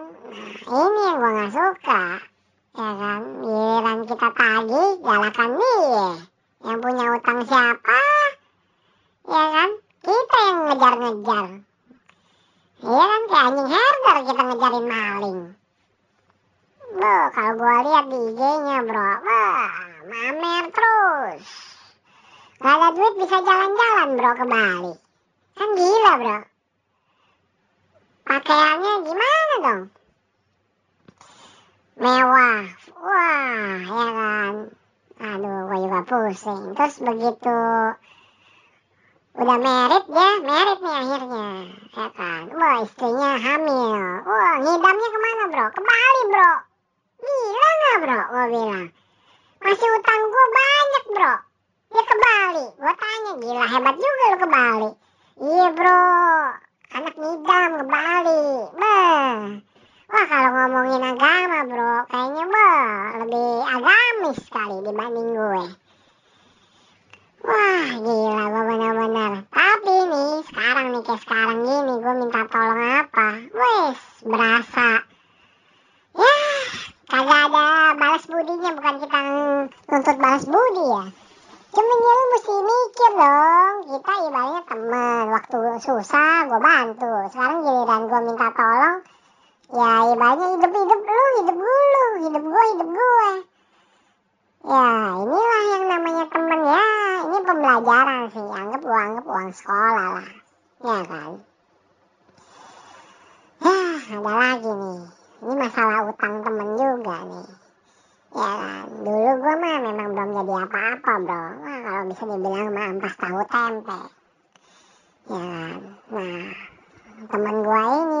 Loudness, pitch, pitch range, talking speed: -19 LUFS, 260 Hz, 225-350 Hz, 120 wpm